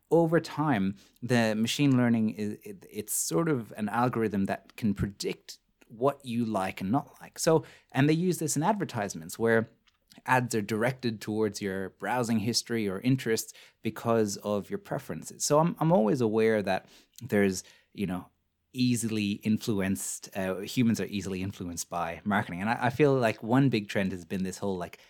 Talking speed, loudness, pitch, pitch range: 170 wpm, -29 LUFS, 115 Hz, 100-125 Hz